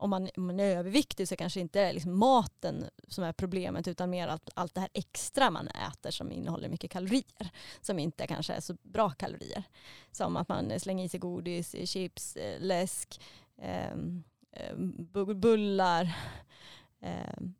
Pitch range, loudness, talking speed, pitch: 175-195 Hz, -33 LUFS, 165 wpm, 185 Hz